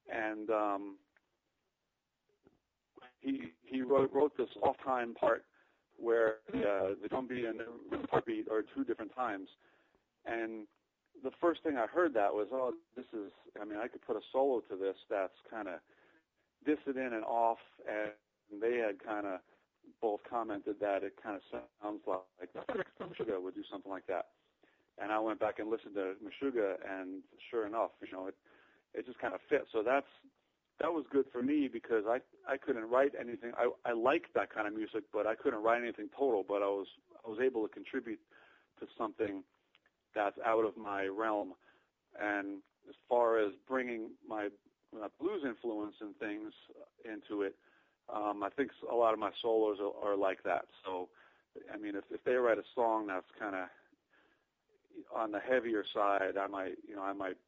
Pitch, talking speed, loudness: 115 Hz, 180 wpm, -37 LUFS